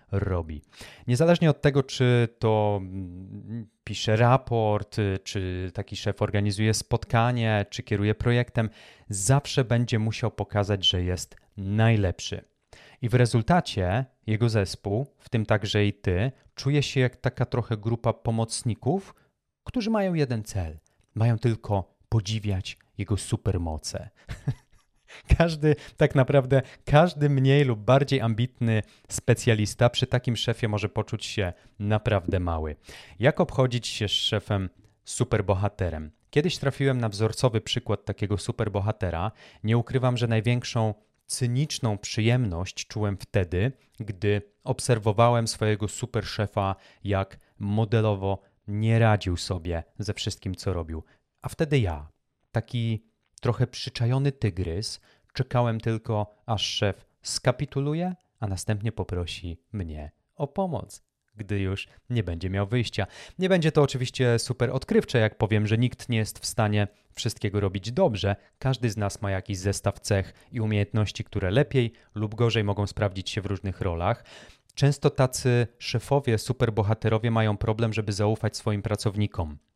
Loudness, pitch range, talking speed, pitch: -26 LUFS, 100-125 Hz, 130 wpm, 110 Hz